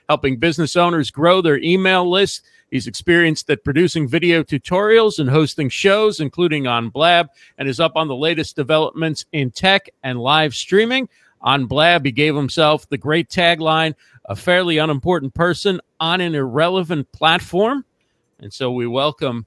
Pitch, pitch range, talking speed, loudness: 160 Hz, 145-175 Hz, 155 wpm, -17 LUFS